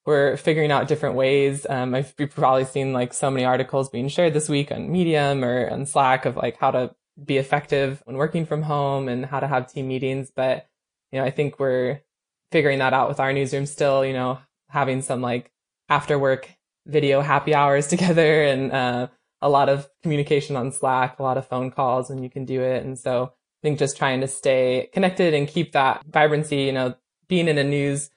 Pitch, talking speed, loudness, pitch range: 140 Hz, 210 wpm, -22 LUFS, 130-145 Hz